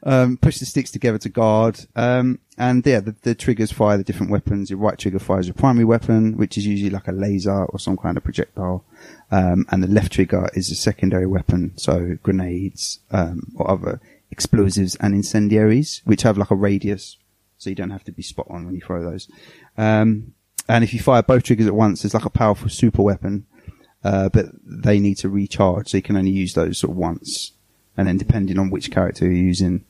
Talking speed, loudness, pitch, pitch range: 220 wpm, -19 LUFS, 100 Hz, 95-110 Hz